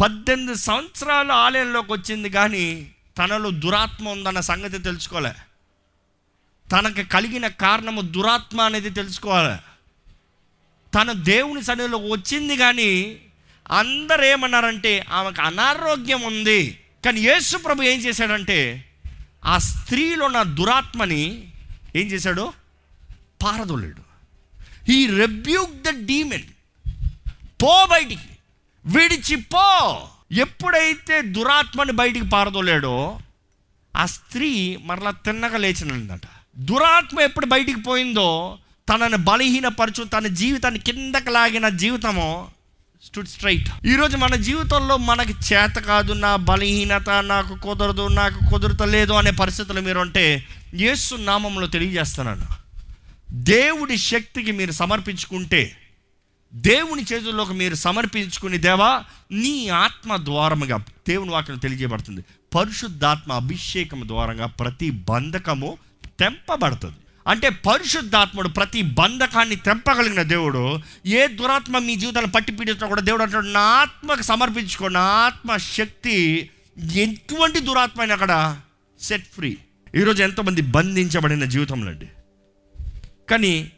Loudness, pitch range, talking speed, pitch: -19 LUFS, 150-235 Hz, 100 wpm, 200 Hz